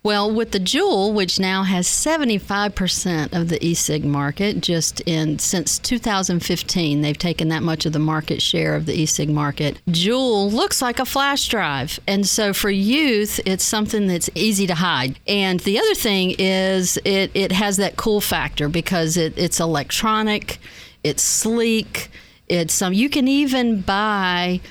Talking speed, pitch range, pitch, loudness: 165 wpm, 165-210 Hz, 190 Hz, -19 LUFS